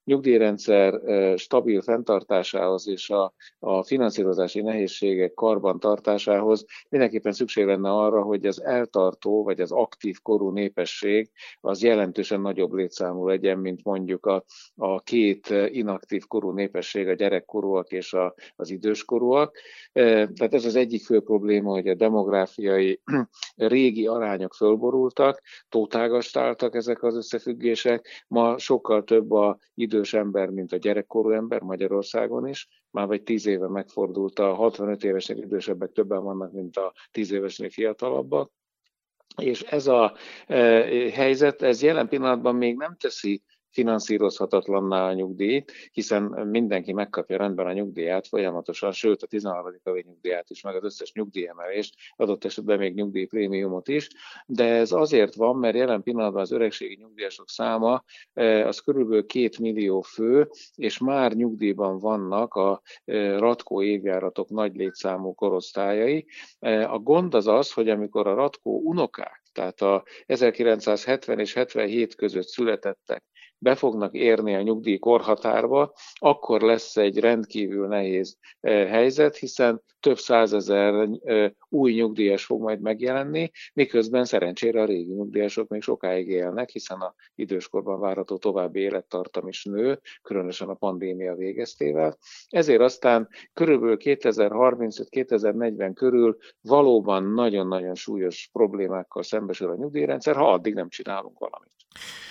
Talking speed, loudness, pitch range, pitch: 125 wpm, -24 LUFS, 95-115 Hz, 105 Hz